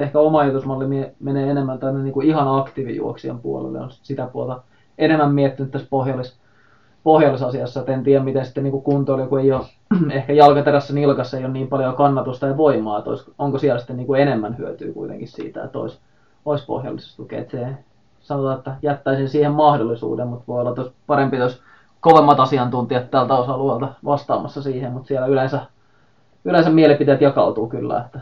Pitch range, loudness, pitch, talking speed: 125-145 Hz, -19 LUFS, 135 Hz, 160 wpm